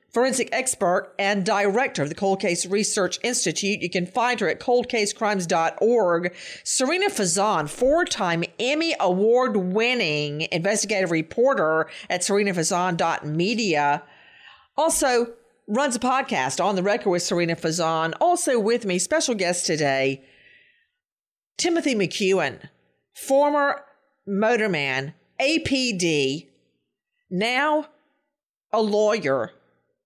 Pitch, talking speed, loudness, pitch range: 205 Hz, 100 wpm, -22 LUFS, 175-260 Hz